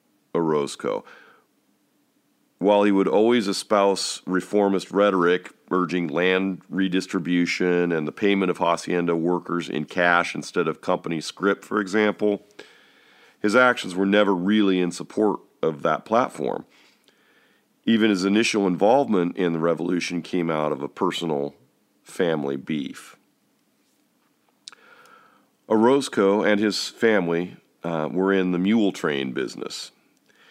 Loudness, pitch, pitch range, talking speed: -22 LUFS, 95 Hz, 85-100 Hz, 120 wpm